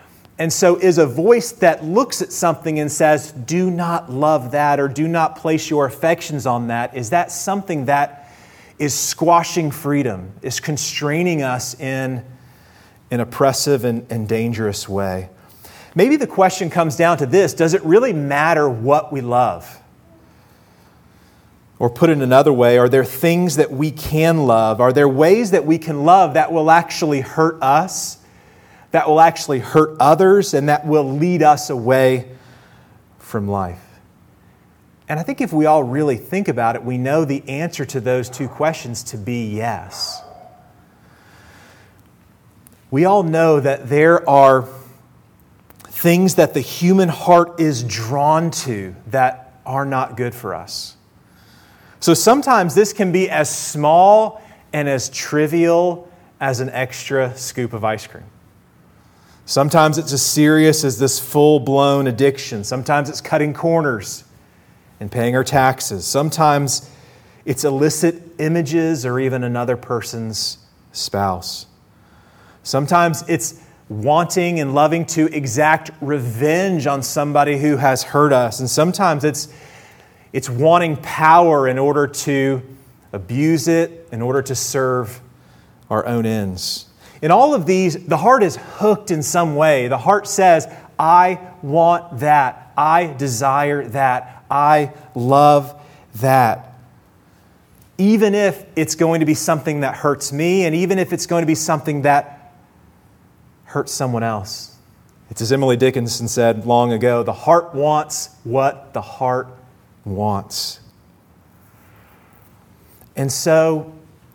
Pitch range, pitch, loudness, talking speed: 125-160 Hz, 145 Hz, -16 LUFS, 140 wpm